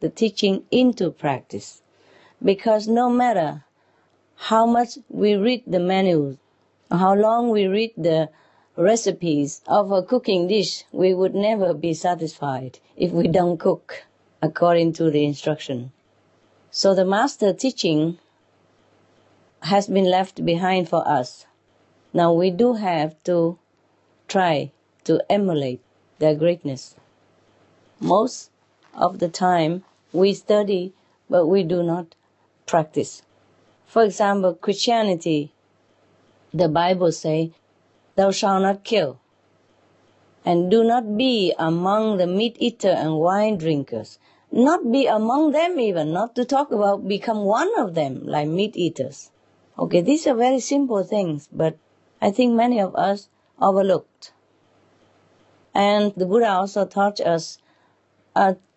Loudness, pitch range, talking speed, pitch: -21 LUFS, 155-210 Hz, 125 wpm, 185 Hz